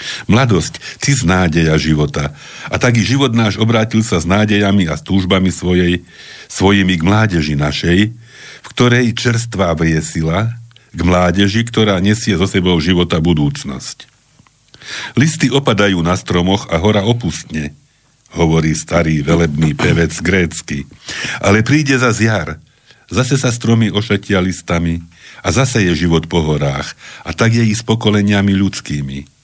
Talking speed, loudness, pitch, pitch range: 135 wpm, -14 LUFS, 95 Hz, 85-110 Hz